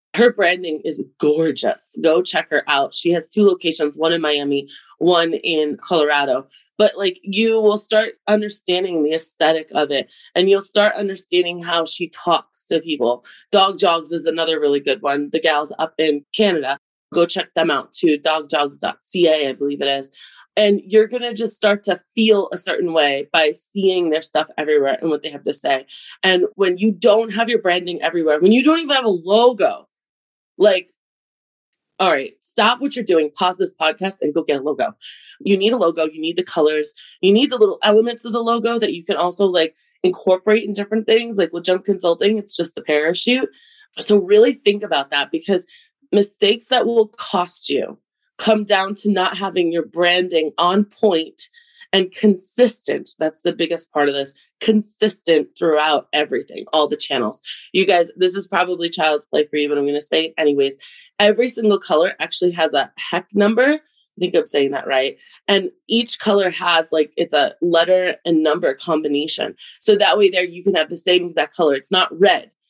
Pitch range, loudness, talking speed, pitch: 160-210 Hz, -18 LUFS, 190 wpm, 180 Hz